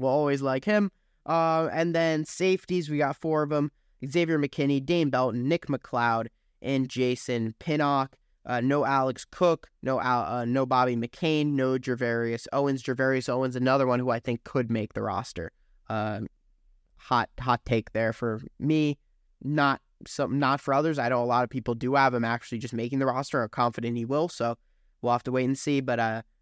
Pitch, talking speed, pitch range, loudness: 130 Hz, 195 wpm, 120-145 Hz, -27 LUFS